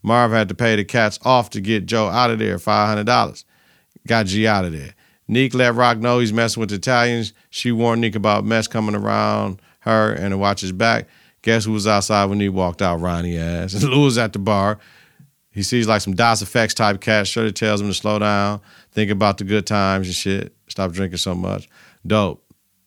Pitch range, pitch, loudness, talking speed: 100-115 Hz, 105 Hz, -19 LUFS, 210 wpm